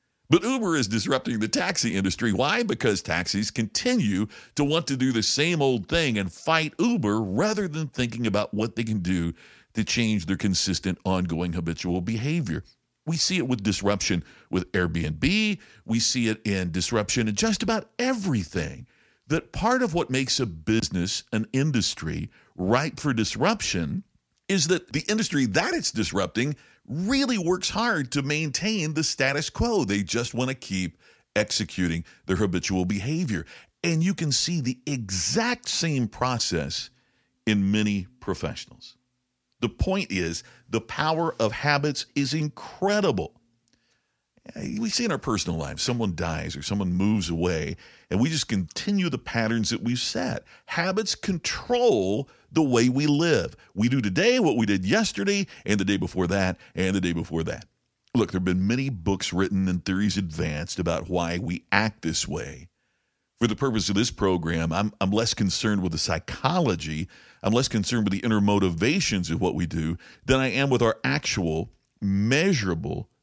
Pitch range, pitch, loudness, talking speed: 95-145 Hz, 115 Hz, -25 LUFS, 165 wpm